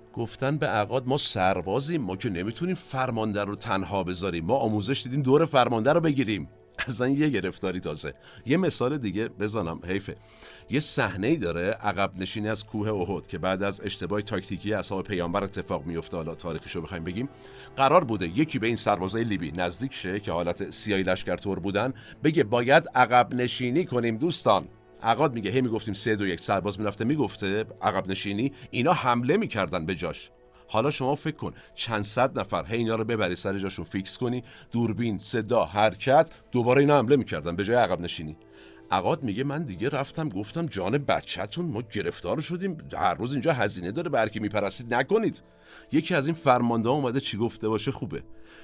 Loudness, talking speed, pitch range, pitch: -26 LUFS, 175 wpm, 100-130 Hz, 110 Hz